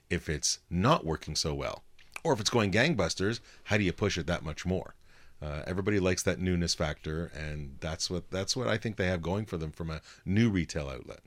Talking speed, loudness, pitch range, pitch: 225 wpm, -31 LUFS, 80-95 Hz, 85 Hz